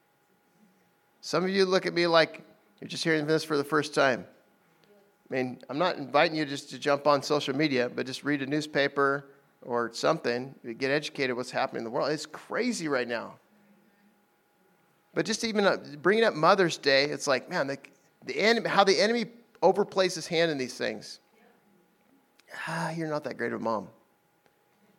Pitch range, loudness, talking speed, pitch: 140-190 Hz, -28 LUFS, 180 wpm, 155 Hz